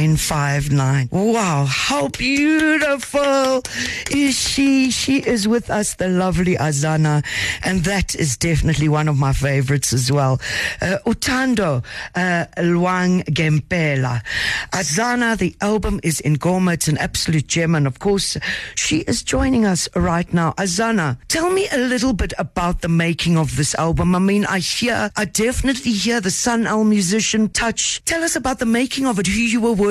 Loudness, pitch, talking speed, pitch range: -18 LUFS, 185 Hz, 165 wpm, 155-235 Hz